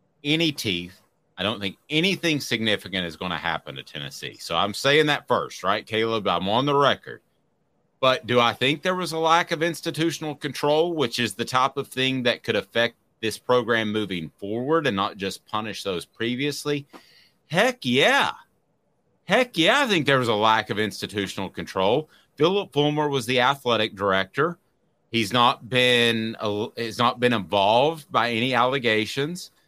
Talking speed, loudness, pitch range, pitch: 170 wpm, -23 LUFS, 110-145 Hz, 120 Hz